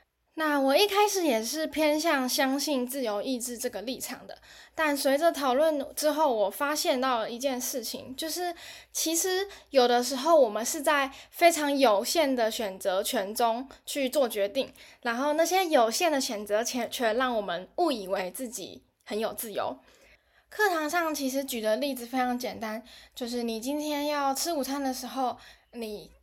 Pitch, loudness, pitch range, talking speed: 270 Hz, -28 LUFS, 240-310 Hz, 250 characters per minute